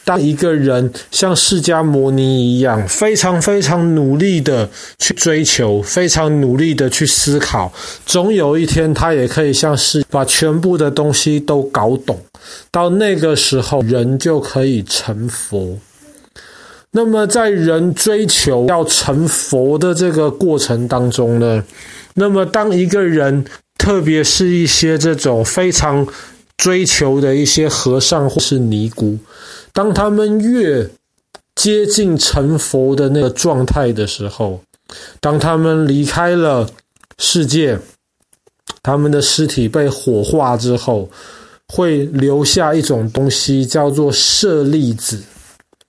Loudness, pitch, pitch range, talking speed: -13 LUFS, 150 Hz, 130-175 Hz, 195 characters per minute